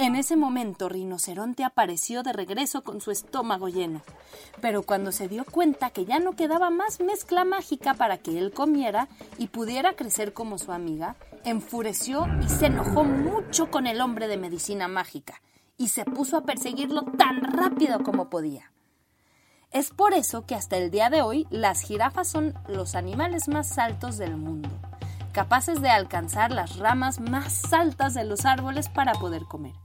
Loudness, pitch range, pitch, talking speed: -26 LUFS, 190-300 Hz, 245 Hz, 170 wpm